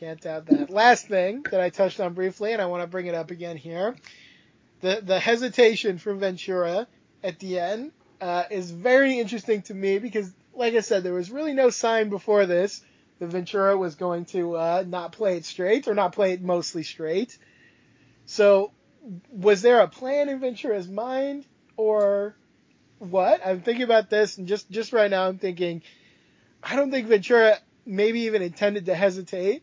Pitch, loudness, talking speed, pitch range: 200 Hz, -24 LUFS, 180 wpm, 185-225 Hz